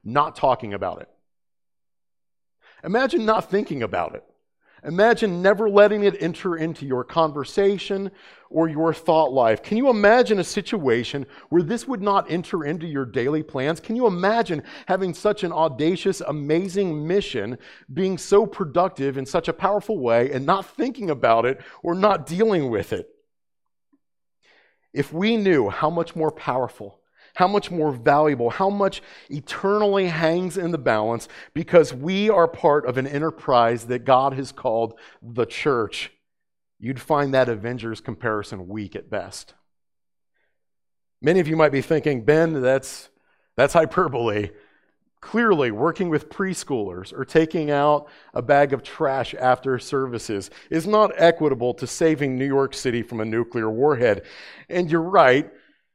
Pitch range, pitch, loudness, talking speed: 130-190 Hz, 155 Hz, -21 LUFS, 150 wpm